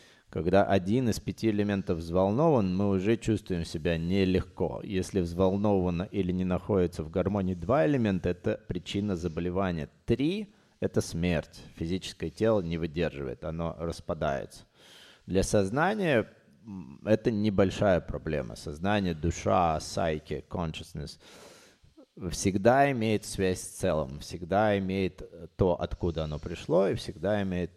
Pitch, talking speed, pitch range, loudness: 95 Hz, 120 wpm, 85-105 Hz, -29 LUFS